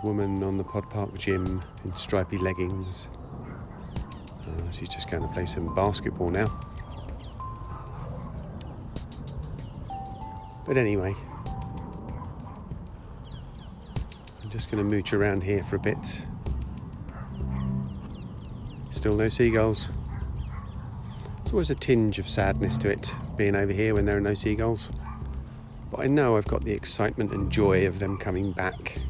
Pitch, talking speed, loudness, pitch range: 100 Hz, 130 wpm, -29 LUFS, 95-110 Hz